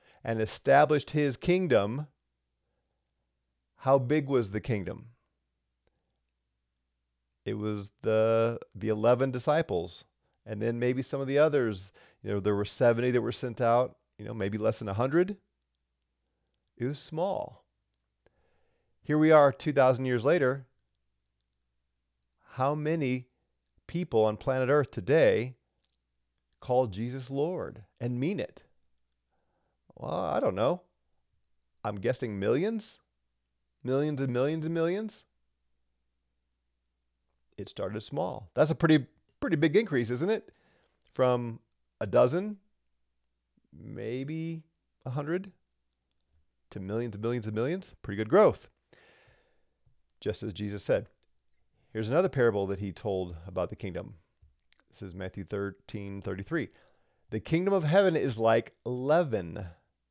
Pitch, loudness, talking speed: 110 Hz, -29 LUFS, 120 wpm